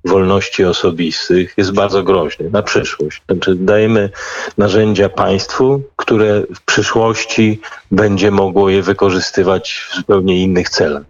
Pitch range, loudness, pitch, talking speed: 95-105 Hz, -13 LUFS, 100 Hz, 120 wpm